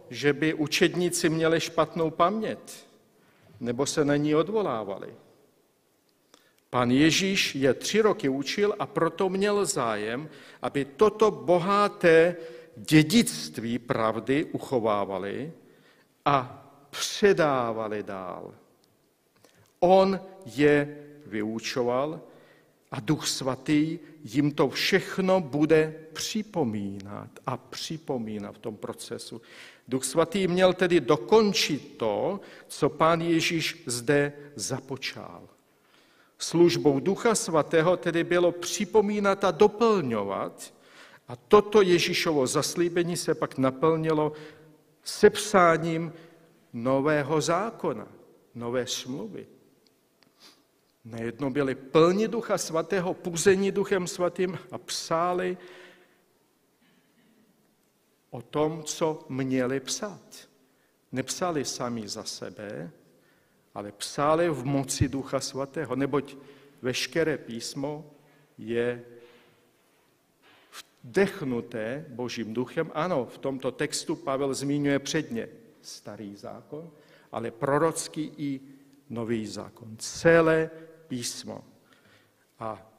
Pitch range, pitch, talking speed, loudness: 130-175 Hz, 150 Hz, 90 wpm, -26 LUFS